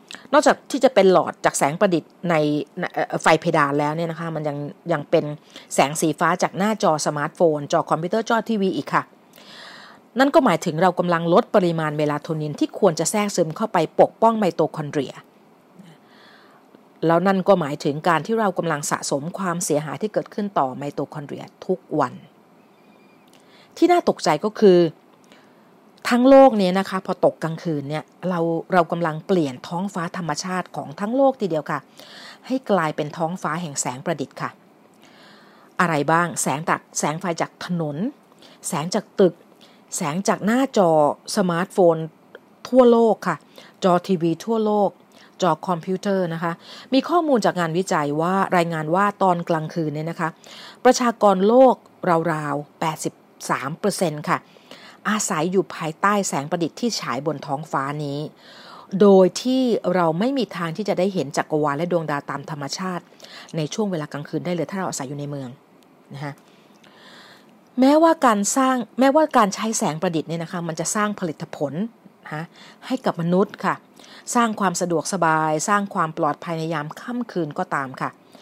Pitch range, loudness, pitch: 160-210 Hz, -21 LUFS, 180 Hz